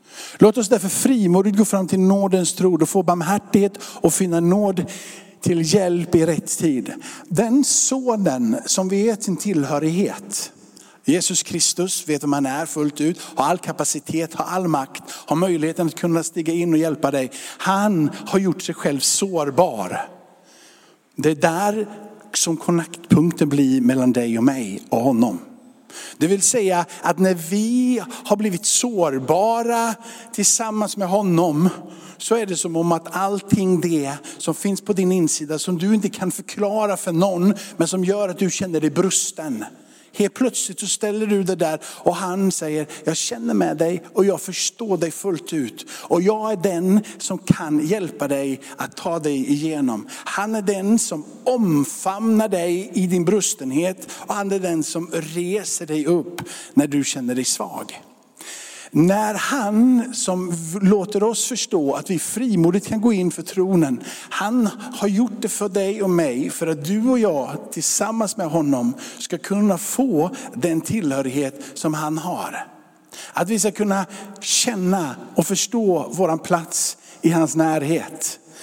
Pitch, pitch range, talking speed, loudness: 185 Hz, 165-210 Hz, 160 wpm, -20 LUFS